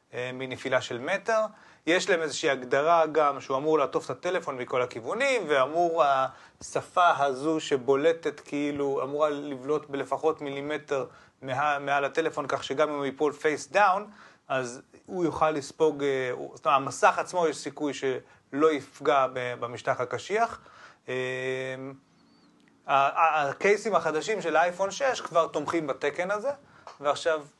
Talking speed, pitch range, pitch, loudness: 125 wpm, 135-170 Hz, 150 Hz, -27 LUFS